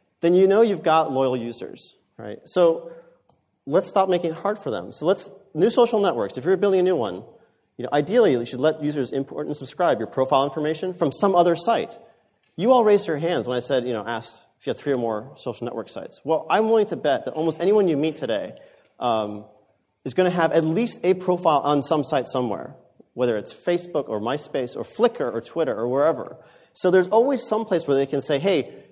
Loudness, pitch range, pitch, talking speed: -22 LUFS, 135-200 Hz, 165 Hz, 225 wpm